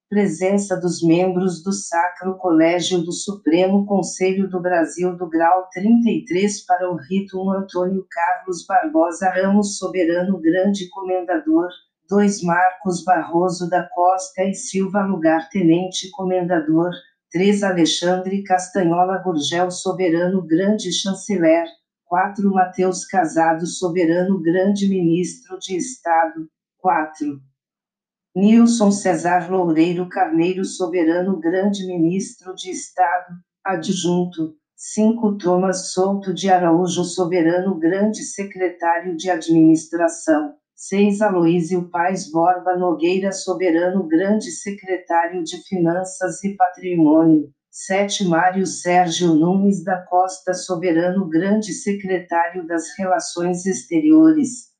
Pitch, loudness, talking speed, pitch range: 185 Hz, -19 LUFS, 105 wpm, 170-195 Hz